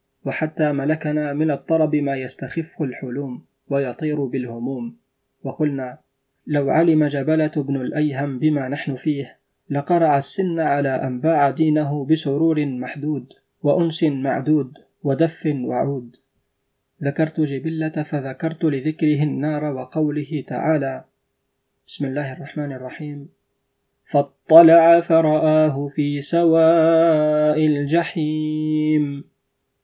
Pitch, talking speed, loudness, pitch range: 150 Hz, 90 wpm, -20 LUFS, 140-155 Hz